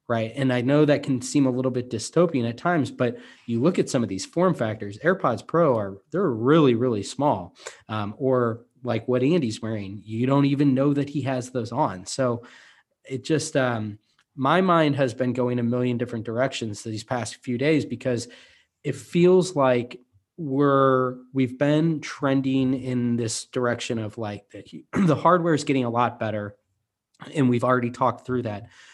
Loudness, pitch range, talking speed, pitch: -24 LUFS, 115-140 Hz, 180 wpm, 125 Hz